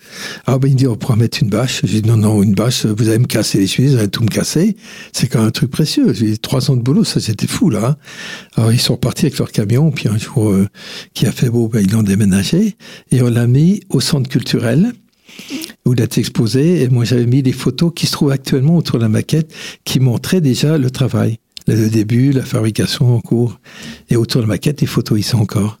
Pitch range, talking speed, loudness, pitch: 115-155 Hz, 255 wpm, -14 LUFS, 130 Hz